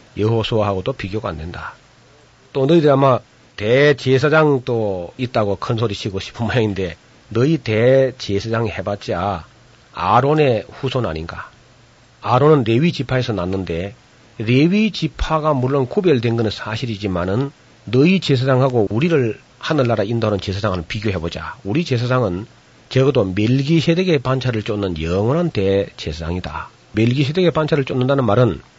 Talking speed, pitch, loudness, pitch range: 325 characters per minute, 120 Hz, -18 LUFS, 100-135 Hz